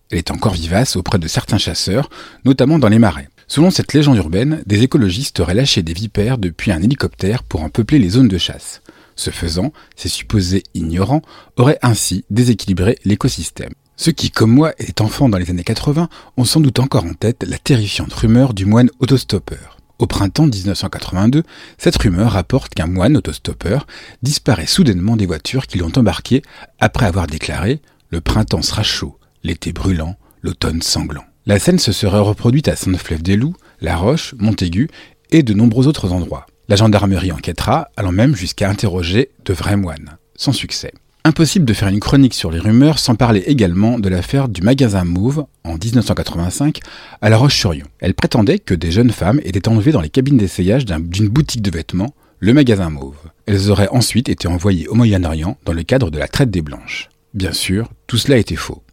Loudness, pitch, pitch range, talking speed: -15 LUFS, 105 Hz, 90-130 Hz, 180 wpm